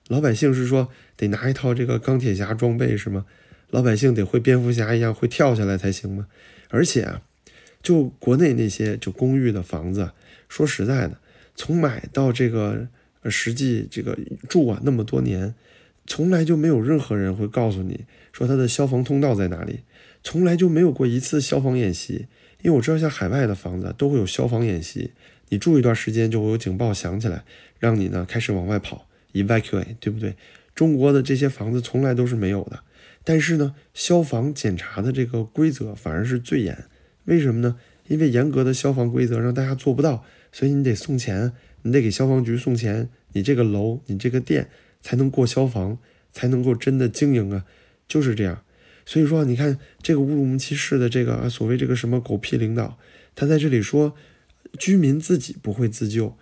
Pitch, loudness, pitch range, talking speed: 125 Hz, -22 LUFS, 110-135 Hz, 300 characters per minute